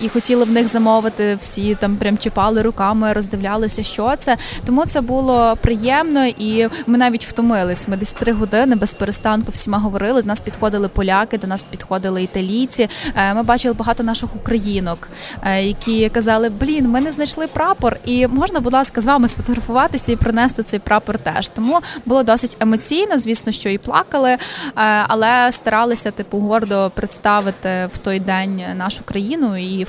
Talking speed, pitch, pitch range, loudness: 160 wpm, 225 Hz, 205-245 Hz, -16 LUFS